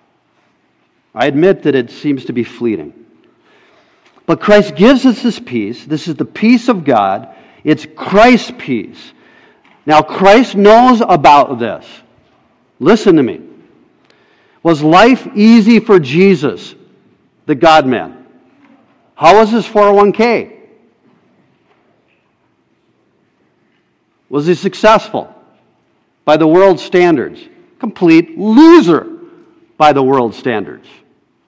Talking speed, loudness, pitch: 105 wpm, -10 LUFS, 210 Hz